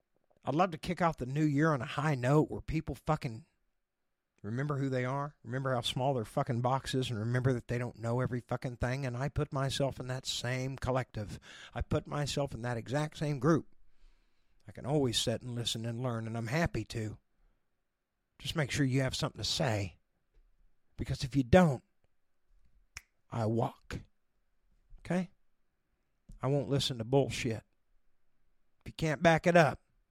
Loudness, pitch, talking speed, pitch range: -33 LUFS, 130 Hz, 175 wpm, 115-145 Hz